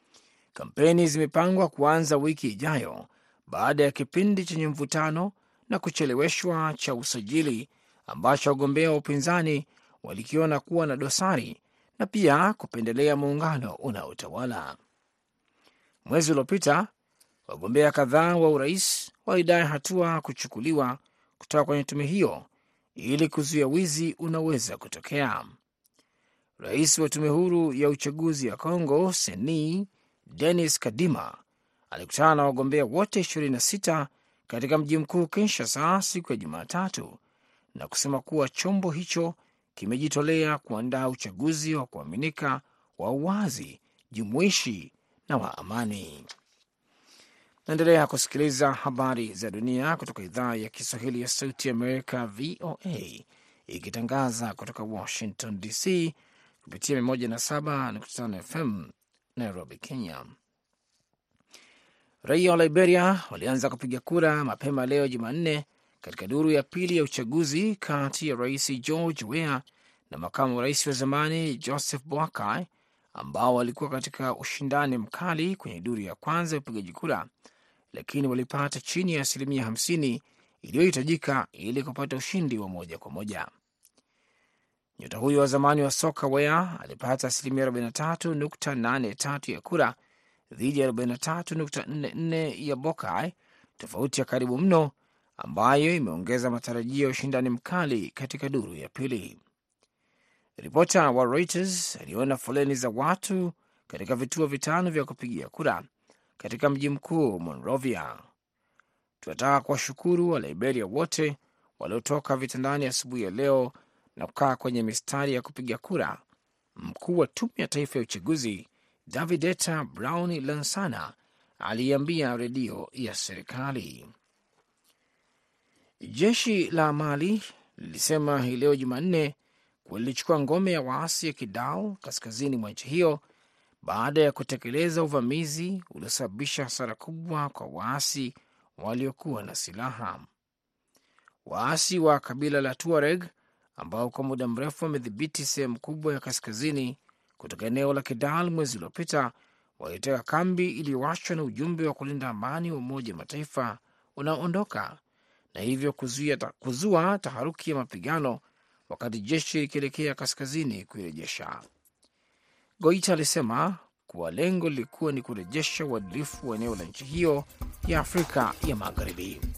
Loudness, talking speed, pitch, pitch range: -28 LUFS, 115 wpm, 145 Hz, 130-160 Hz